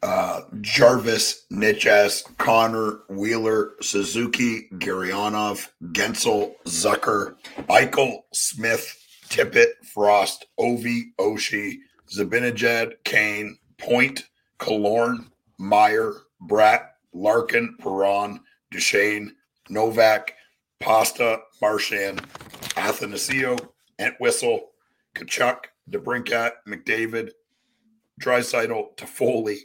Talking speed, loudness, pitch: 70 wpm, -22 LUFS, 115 Hz